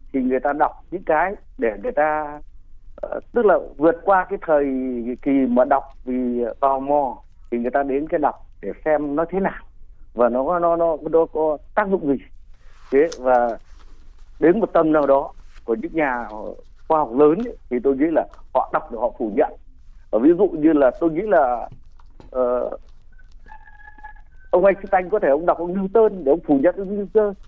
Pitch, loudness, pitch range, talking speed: 150 Hz, -20 LUFS, 130-190 Hz, 195 wpm